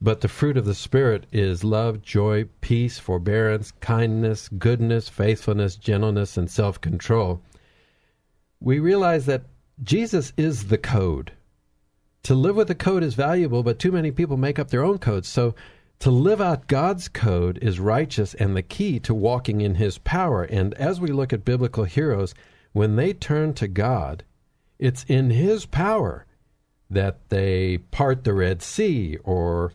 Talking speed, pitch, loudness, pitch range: 160 wpm, 110 Hz, -23 LUFS, 100-135 Hz